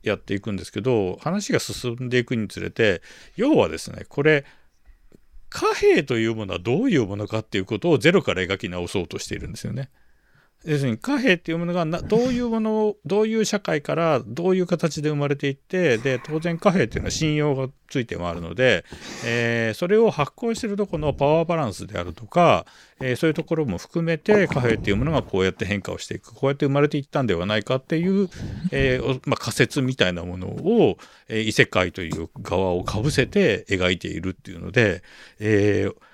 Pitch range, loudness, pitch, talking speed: 110-170 Hz, -23 LUFS, 135 Hz, 420 characters per minute